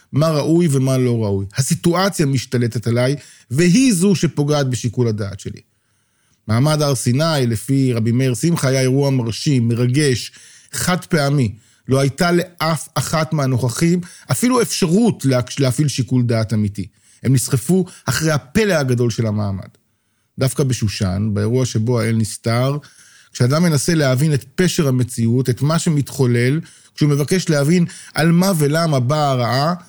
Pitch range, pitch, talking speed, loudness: 120-160 Hz, 135 Hz, 135 wpm, -17 LUFS